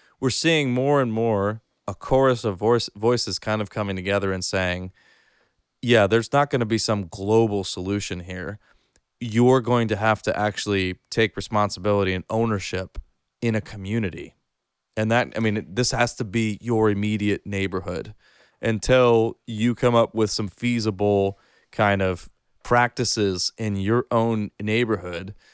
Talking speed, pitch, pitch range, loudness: 150 wpm, 110 Hz, 100-115 Hz, -23 LUFS